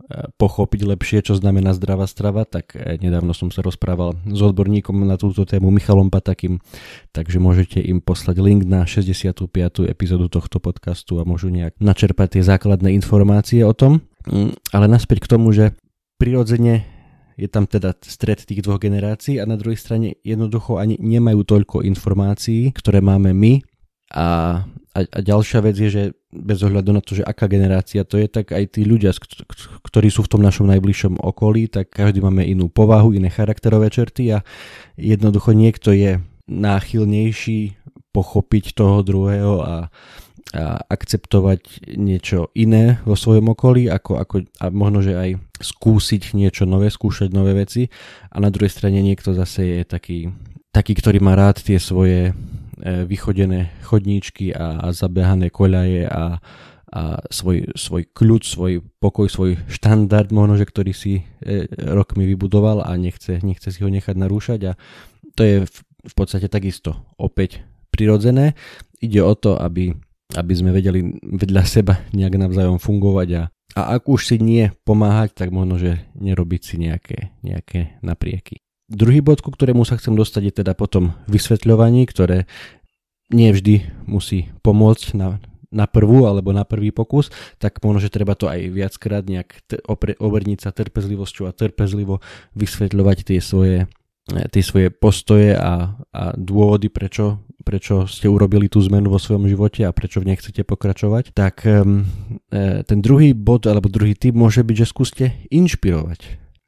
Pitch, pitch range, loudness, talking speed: 100 Hz, 95-110 Hz, -17 LUFS, 155 wpm